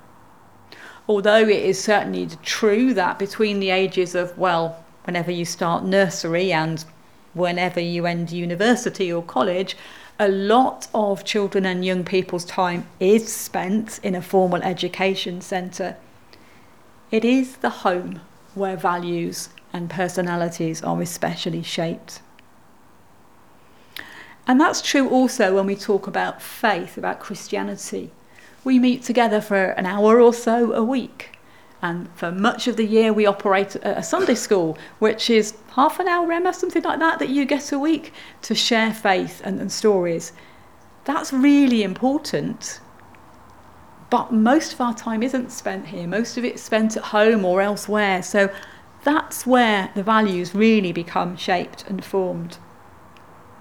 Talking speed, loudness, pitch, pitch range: 145 wpm, -21 LUFS, 200 Hz, 180-230 Hz